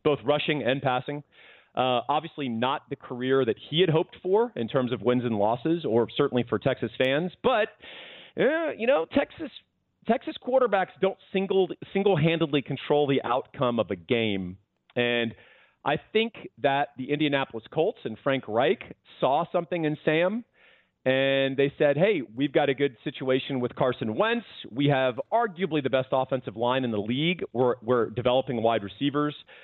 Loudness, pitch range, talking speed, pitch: -26 LUFS, 125-165 Hz, 165 wpm, 140 Hz